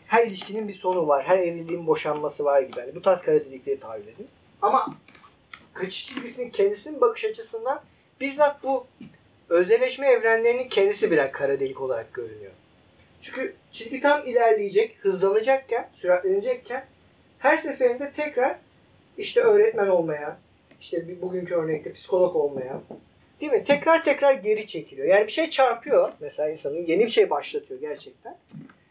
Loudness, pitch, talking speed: -24 LUFS, 255 Hz, 140 wpm